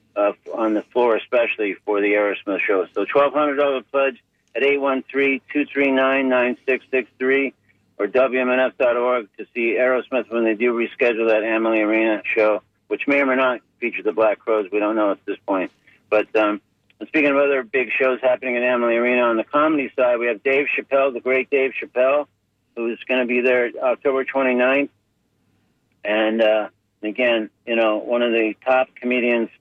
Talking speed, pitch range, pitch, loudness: 165 wpm, 110-130 Hz, 125 Hz, -20 LUFS